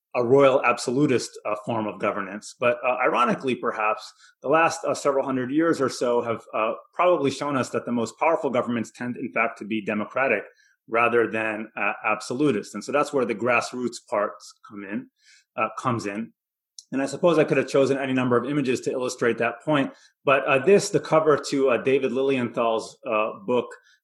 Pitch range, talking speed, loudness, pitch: 115-140 Hz, 190 wpm, -24 LUFS, 125 Hz